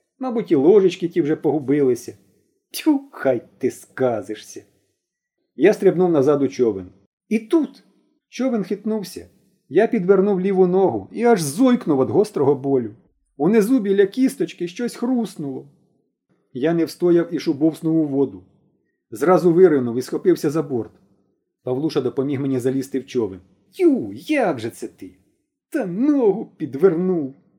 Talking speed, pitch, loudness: 135 wpm, 180 Hz, -20 LUFS